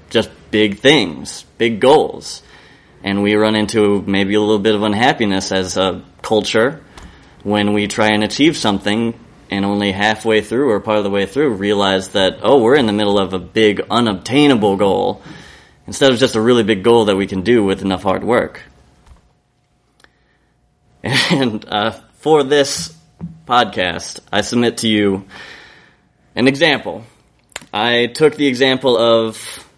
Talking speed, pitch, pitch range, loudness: 155 wpm, 105 Hz, 100-120 Hz, -15 LUFS